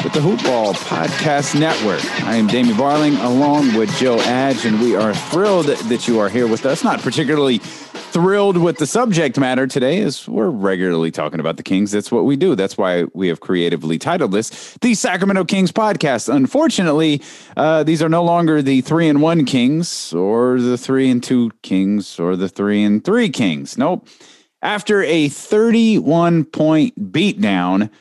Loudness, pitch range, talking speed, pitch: -16 LUFS, 110-170 Hz, 175 wpm, 145 Hz